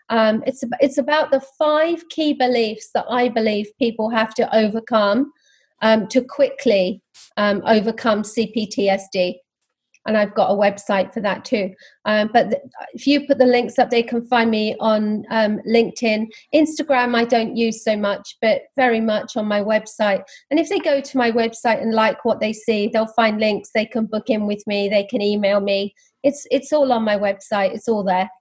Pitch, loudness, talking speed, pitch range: 225 Hz, -19 LUFS, 190 wpm, 210-255 Hz